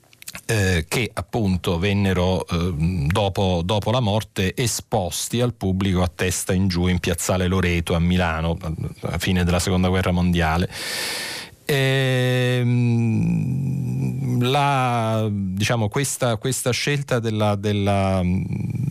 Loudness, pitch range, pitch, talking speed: -21 LUFS, 90-120 Hz, 100 Hz, 110 wpm